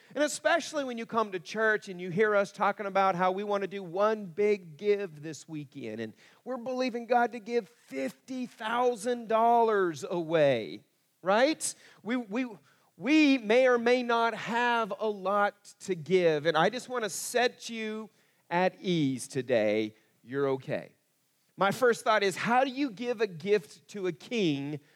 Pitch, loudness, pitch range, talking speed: 210 Hz, -29 LUFS, 180-240 Hz, 165 wpm